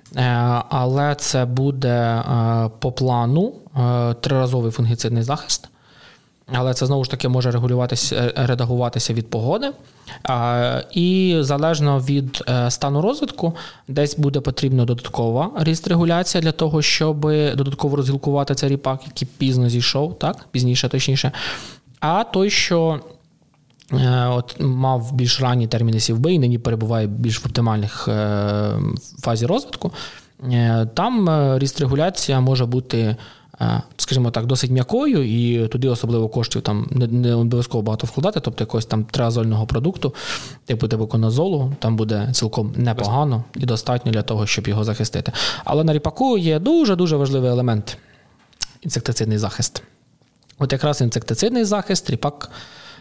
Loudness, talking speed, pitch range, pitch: -20 LUFS, 125 wpm, 120-145 Hz, 130 Hz